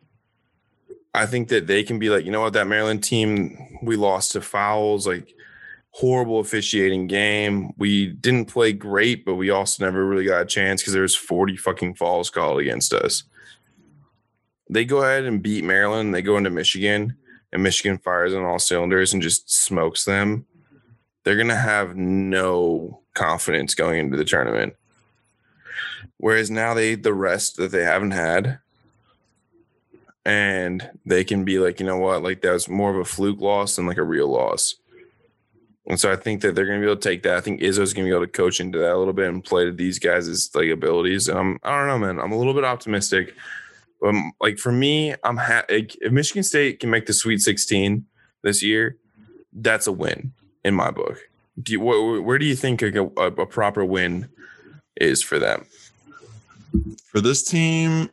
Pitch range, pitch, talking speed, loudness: 95-120 Hz, 105 Hz, 195 wpm, -21 LUFS